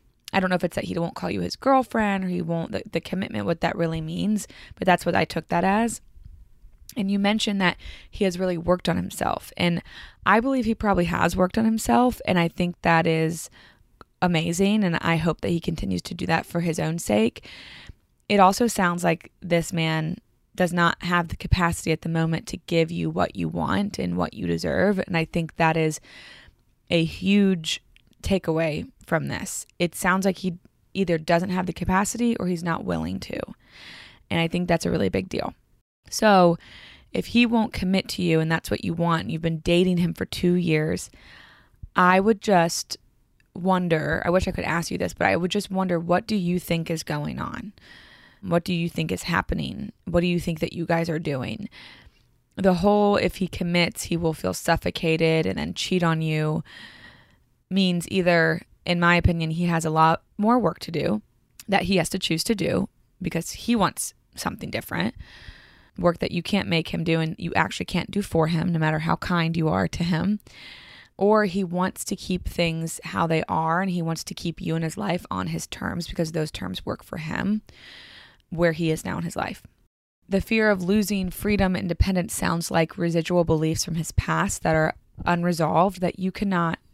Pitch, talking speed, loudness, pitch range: 170 Hz, 205 wpm, -24 LUFS, 165-190 Hz